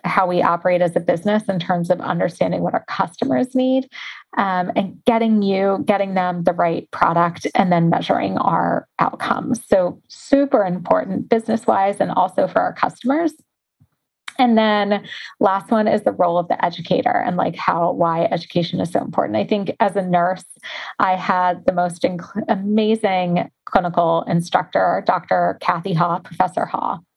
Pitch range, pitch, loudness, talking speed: 175-225 Hz, 195 Hz, -19 LUFS, 165 wpm